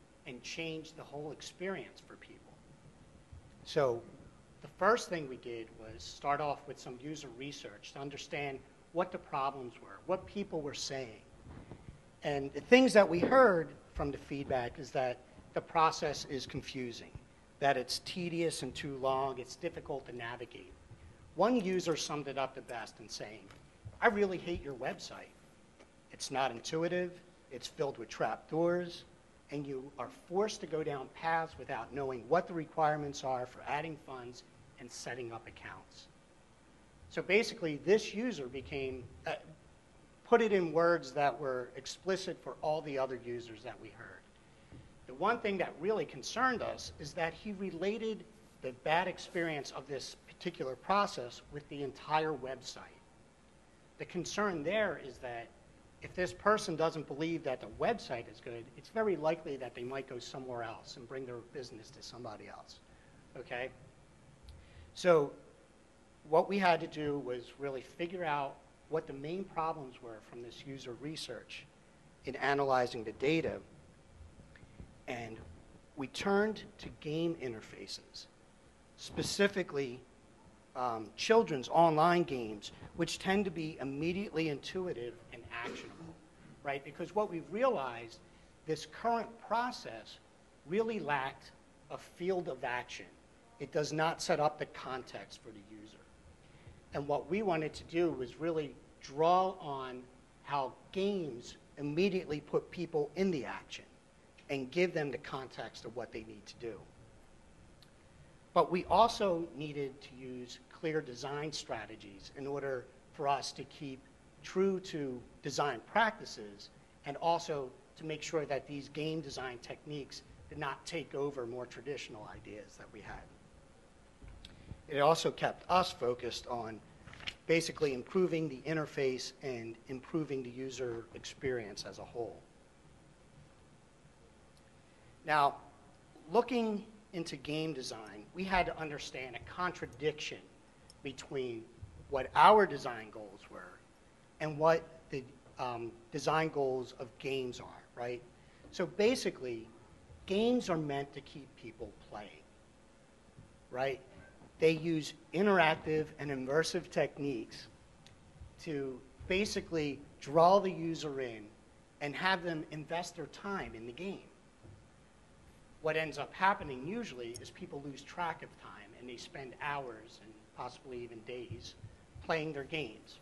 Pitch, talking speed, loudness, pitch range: 145 Hz, 140 wpm, -36 LUFS, 125-170 Hz